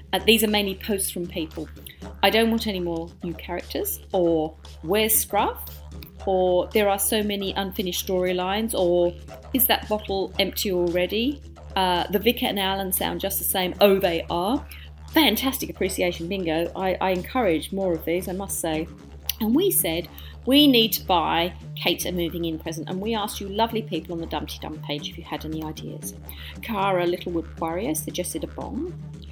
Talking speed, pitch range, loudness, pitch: 180 wpm, 160-200 Hz, -24 LUFS, 180 Hz